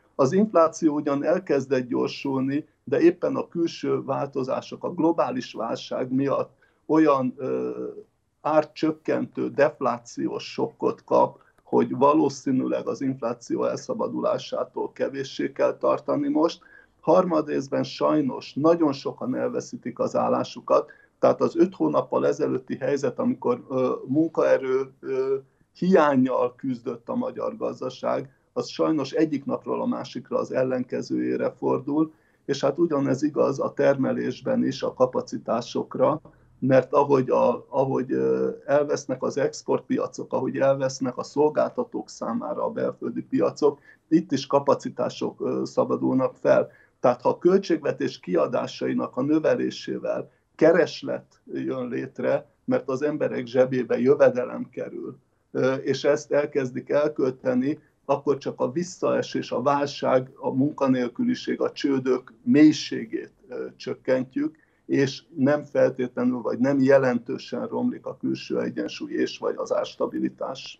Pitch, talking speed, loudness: 150 Hz, 115 wpm, -25 LUFS